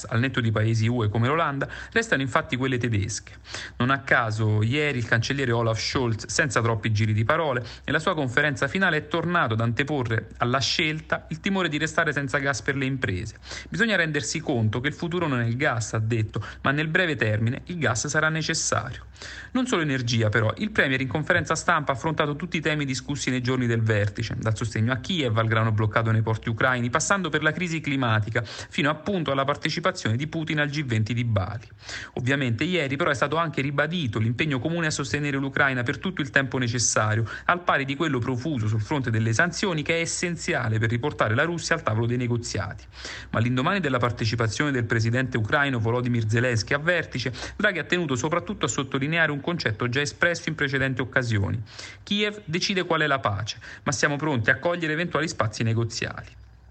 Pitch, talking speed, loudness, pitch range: 135 Hz, 195 wpm, -25 LUFS, 115-155 Hz